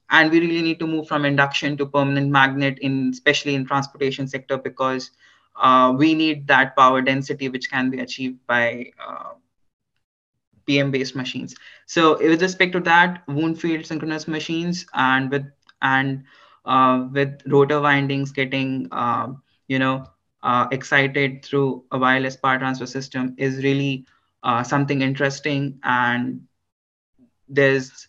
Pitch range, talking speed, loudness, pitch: 130-145 Hz, 145 wpm, -20 LUFS, 135 Hz